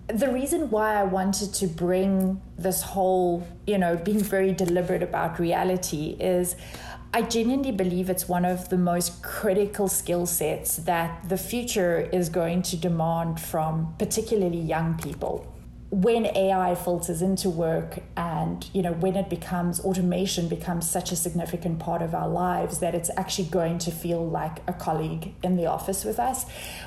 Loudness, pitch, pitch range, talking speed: -26 LUFS, 180 Hz, 170-190 Hz, 165 wpm